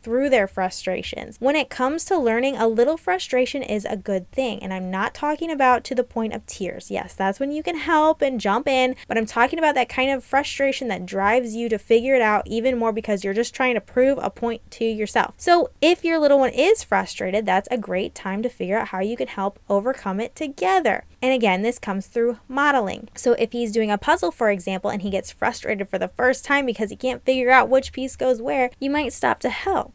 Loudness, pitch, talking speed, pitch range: -22 LUFS, 245 Hz, 235 wpm, 210-270 Hz